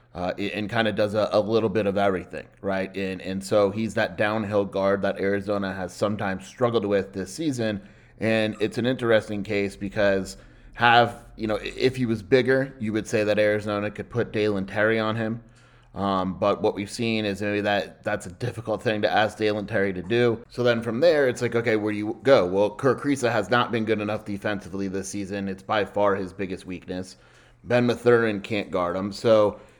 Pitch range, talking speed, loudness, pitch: 100-115 Hz, 205 wpm, -24 LUFS, 105 Hz